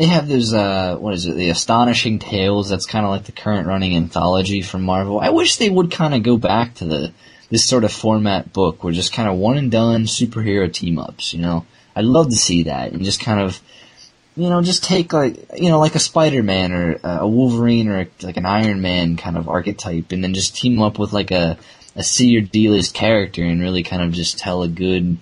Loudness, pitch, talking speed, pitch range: -17 LUFS, 100 Hz, 235 wpm, 90-115 Hz